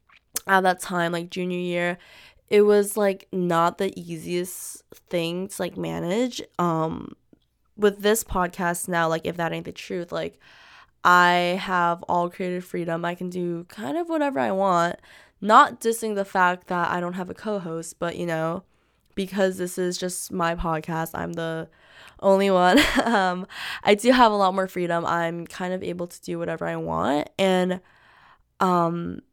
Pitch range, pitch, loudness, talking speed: 170-190 Hz, 180 Hz, -24 LUFS, 170 wpm